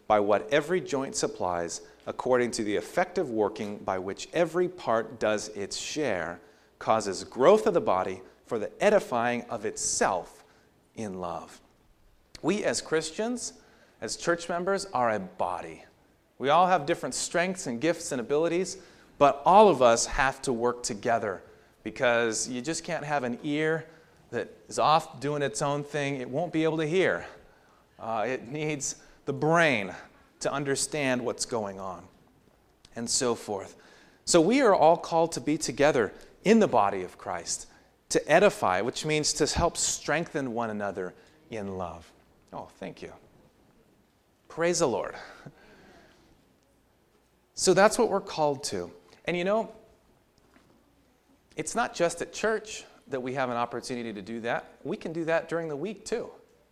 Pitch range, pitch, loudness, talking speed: 120-170 Hz, 150 Hz, -27 LUFS, 155 wpm